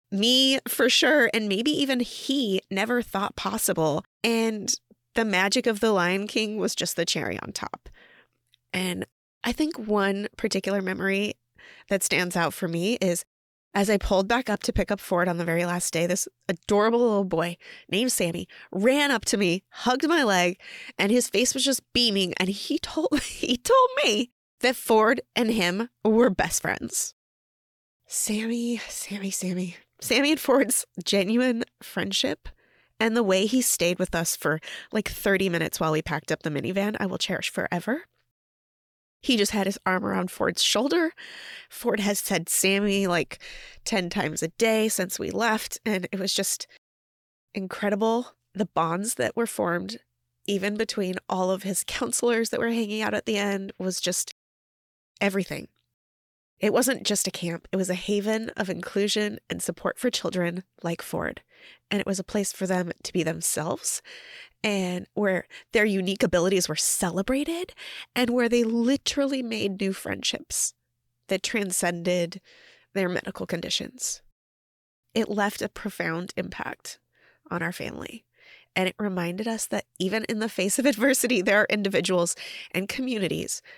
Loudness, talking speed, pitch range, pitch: -25 LUFS, 160 wpm, 180-235 Hz, 200 Hz